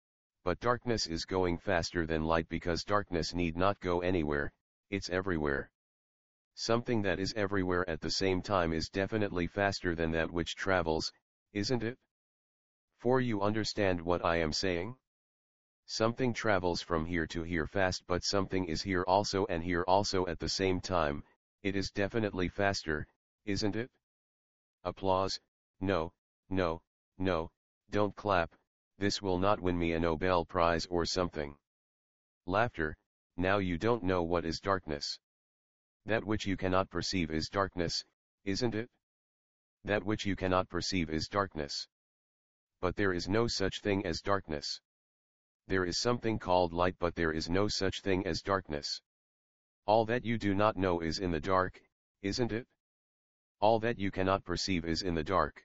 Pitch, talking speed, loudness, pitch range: 95 Hz, 155 wpm, -33 LUFS, 85-100 Hz